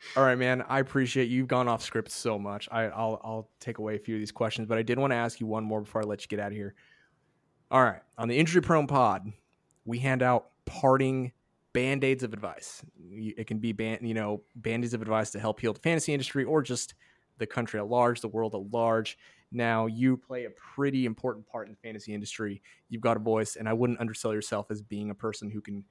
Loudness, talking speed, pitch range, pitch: -30 LUFS, 245 wpm, 110-125 Hz, 115 Hz